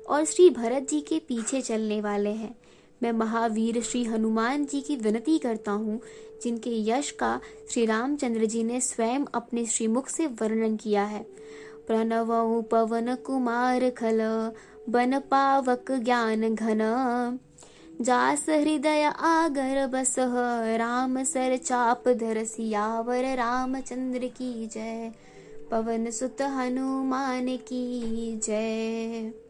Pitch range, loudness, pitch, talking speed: 225-265 Hz, -27 LUFS, 245 Hz, 110 wpm